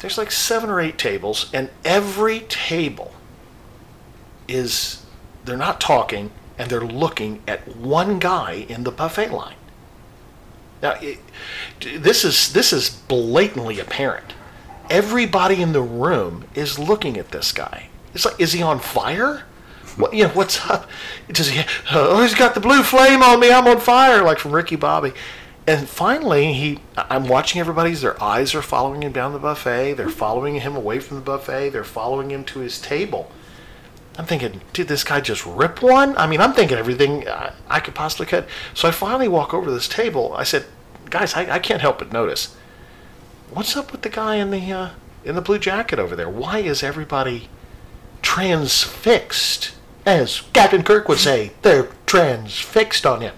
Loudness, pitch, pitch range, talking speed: -18 LUFS, 165 Hz, 135-215 Hz, 175 wpm